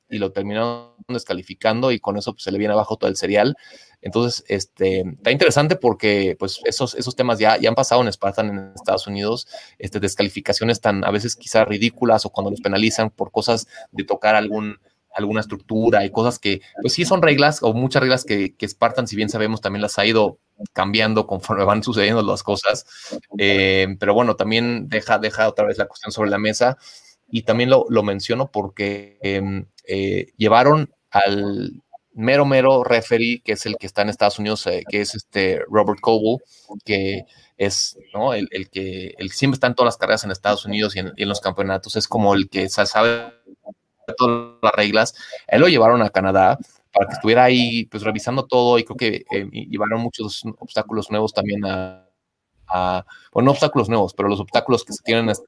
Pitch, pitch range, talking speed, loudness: 110 Hz, 100-120 Hz, 200 wpm, -19 LUFS